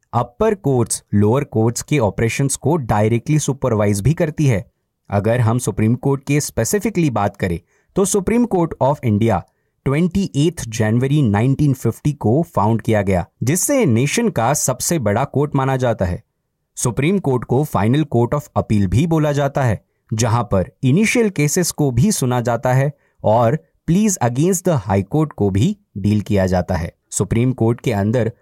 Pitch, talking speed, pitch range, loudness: 130 Hz, 125 wpm, 110-150 Hz, -18 LUFS